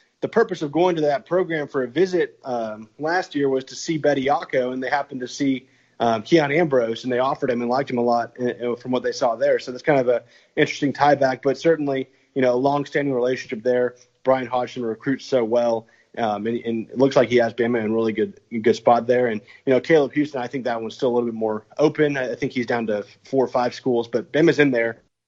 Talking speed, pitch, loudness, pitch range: 255 wpm, 125 Hz, -22 LUFS, 120-145 Hz